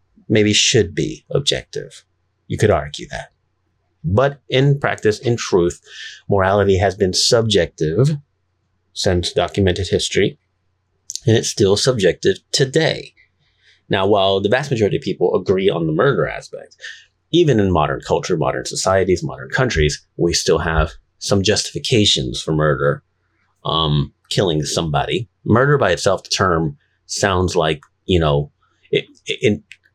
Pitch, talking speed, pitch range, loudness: 95 Hz, 135 wpm, 85-105 Hz, -17 LUFS